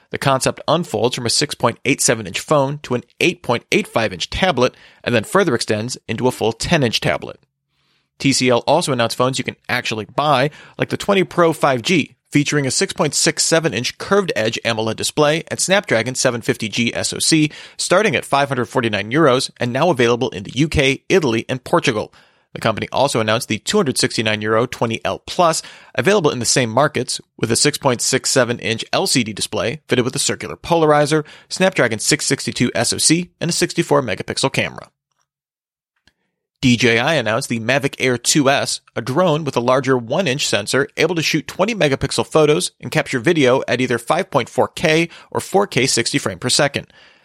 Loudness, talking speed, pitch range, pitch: -17 LUFS, 160 wpm, 115-155 Hz, 130 Hz